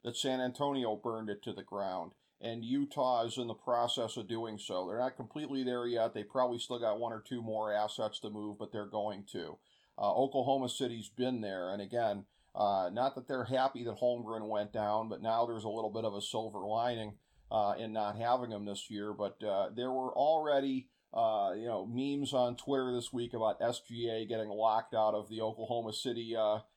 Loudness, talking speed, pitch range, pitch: -36 LUFS, 210 wpm, 110-125 Hz, 115 Hz